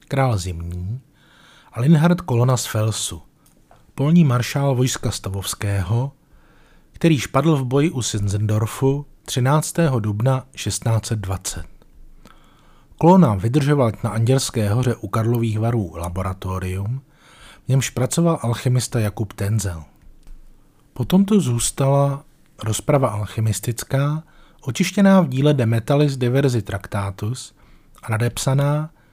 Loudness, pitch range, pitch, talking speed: -20 LUFS, 110-145 Hz, 125 Hz, 100 wpm